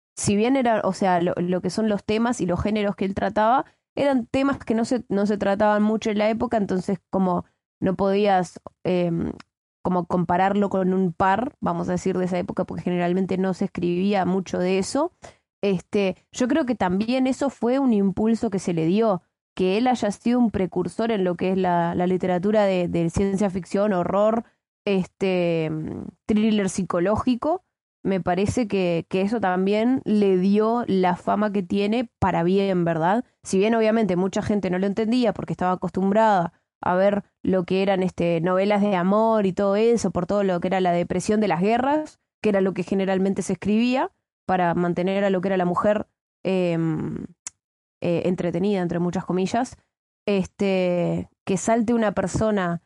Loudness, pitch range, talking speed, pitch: -23 LUFS, 180-215 Hz, 185 wpm, 195 Hz